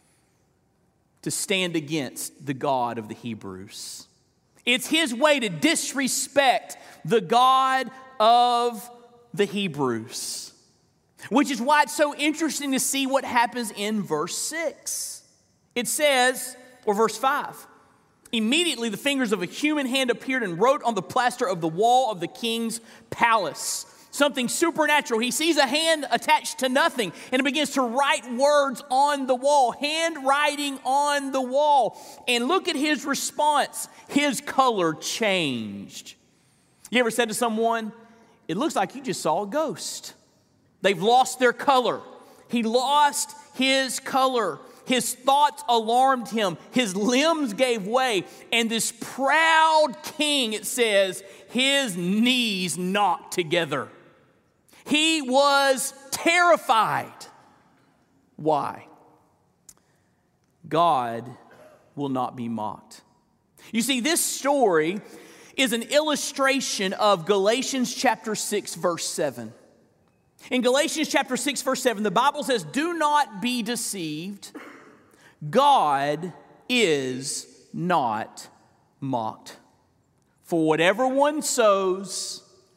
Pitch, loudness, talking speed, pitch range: 250 Hz, -23 LUFS, 120 wpm, 205-285 Hz